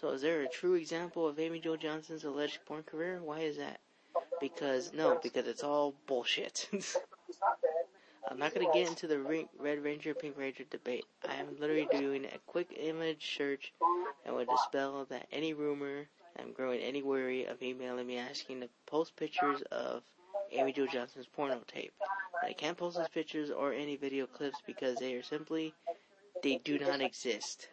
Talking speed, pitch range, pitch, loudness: 180 wpm, 140-165 Hz, 150 Hz, -37 LUFS